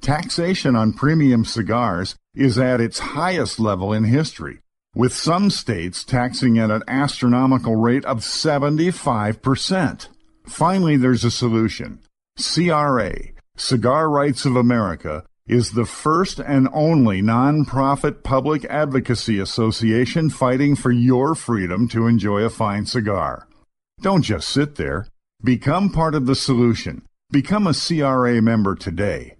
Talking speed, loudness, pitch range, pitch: 125 wpm, -19 LUFS, 115-145 Hz, 125 Hz